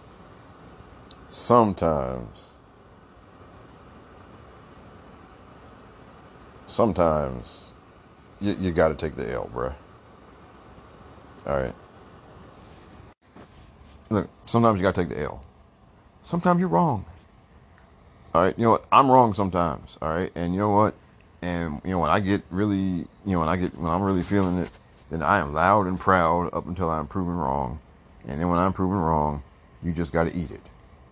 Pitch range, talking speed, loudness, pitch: 80-95 Hz, 150 wpm, -24 LUFS, 90 Hz